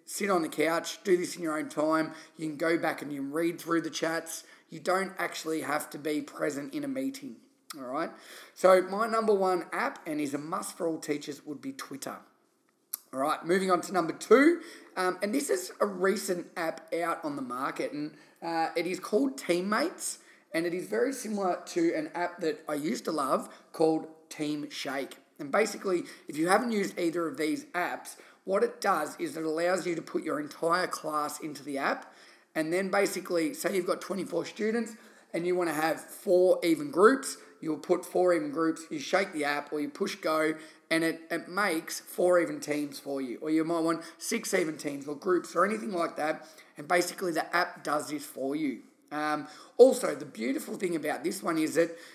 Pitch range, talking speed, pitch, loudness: 155-195 Hz, 210 wpm, 170 Hz, -30 LUFS